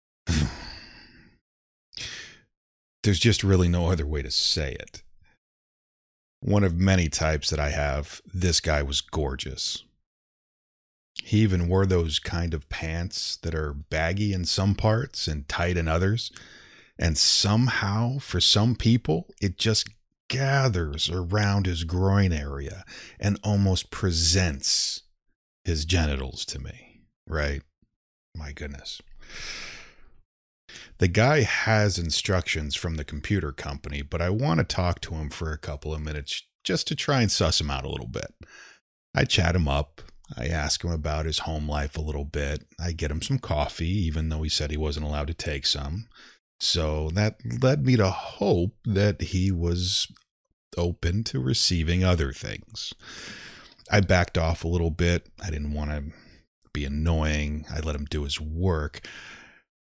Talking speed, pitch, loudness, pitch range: 150 wpm, 85 Hz, -26 LUFS, 75-95 Hz